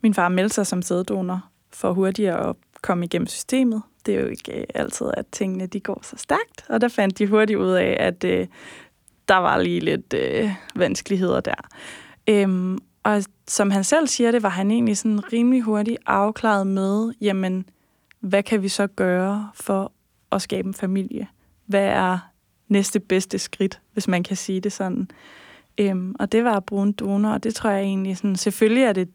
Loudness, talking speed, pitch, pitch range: -22 LUFS, 195 wpm, 200 Hz, 190-215 Hz